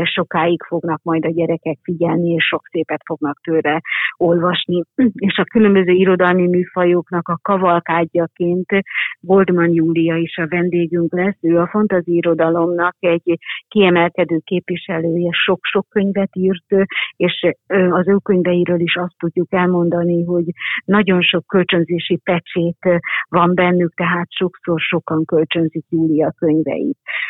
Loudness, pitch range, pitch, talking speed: -16 LUFS, 170-180 Hz, 175 Hz, 125 wpm